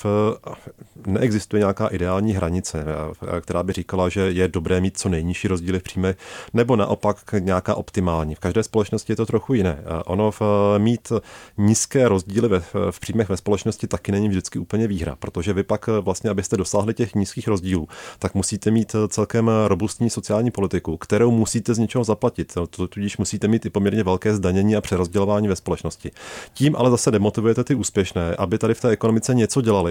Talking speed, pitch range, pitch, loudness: 175 wpm, 95-110 Hz, 105 Hz, -21 LUFS